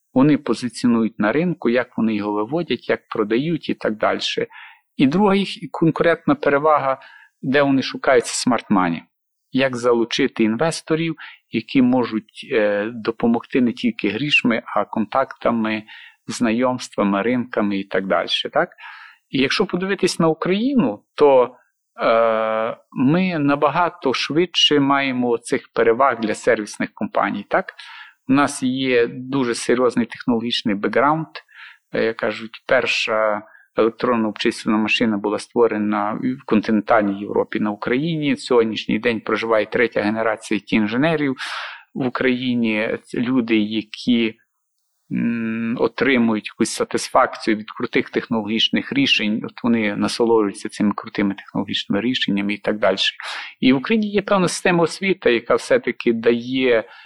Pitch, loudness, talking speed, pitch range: 125 Hz, -19 LUFS, 120 wpm, 110-165 Hz